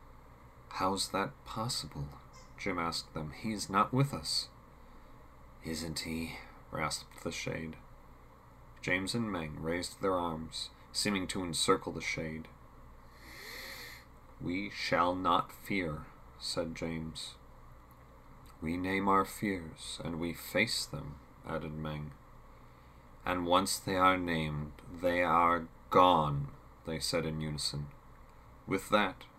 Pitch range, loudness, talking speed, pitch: 65-90 Hz, -34 LUFS, 115 wpm, 80 Hz